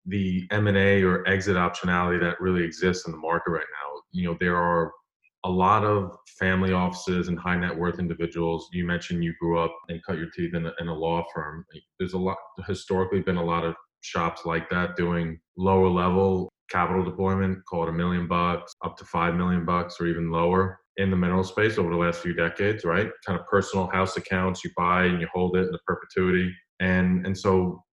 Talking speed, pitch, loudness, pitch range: 215 wpm, 90 Hz, -25 LUFS, 85-95 Hz